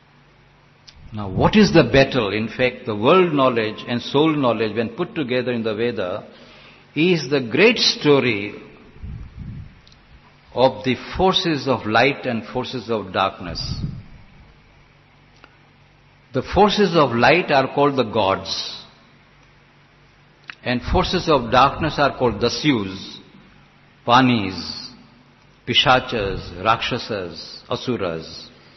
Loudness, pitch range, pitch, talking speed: -19 LUFS, 115-145 Hz, 125 Hz, 105 wpm